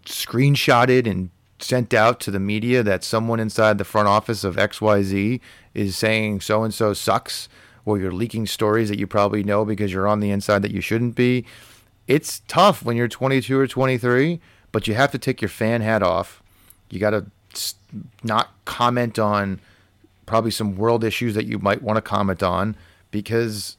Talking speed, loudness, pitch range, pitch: 185 wpm, -21 LUFS, 100-120 Hz, 110 Hz